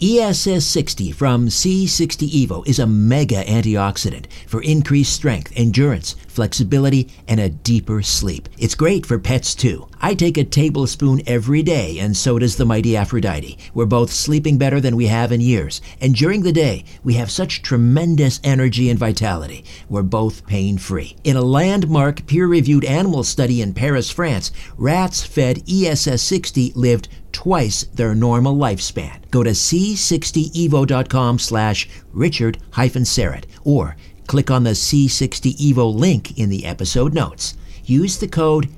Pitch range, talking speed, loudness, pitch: 105-145 Hz, 145 wpm, -17 LUFS, 125 Hz